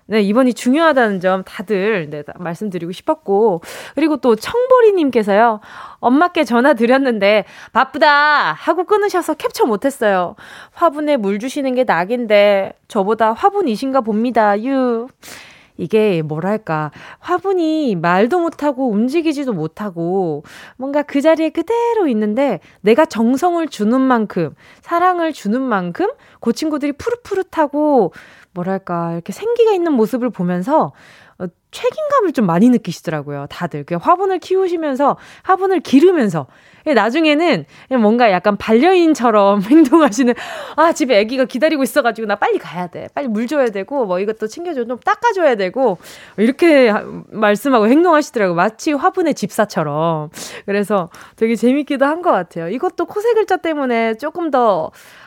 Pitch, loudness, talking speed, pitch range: 255 Hz, -16 LUFS, 330 characters per minute, 205-315 Hz